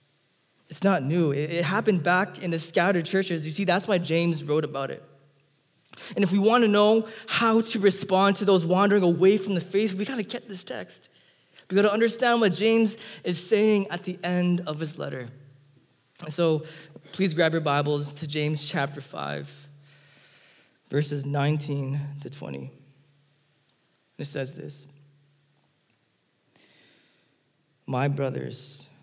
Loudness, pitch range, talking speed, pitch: -25 LUFS, 145-195 Hz, 150 wpm, 160 Hz